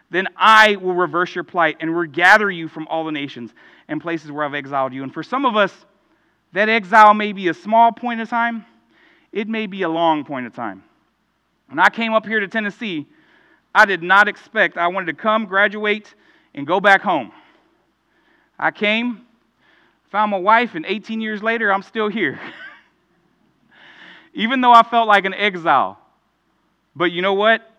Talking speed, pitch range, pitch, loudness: 180 wpm, 170-225 Hz, 205 Hz, -17 LUFS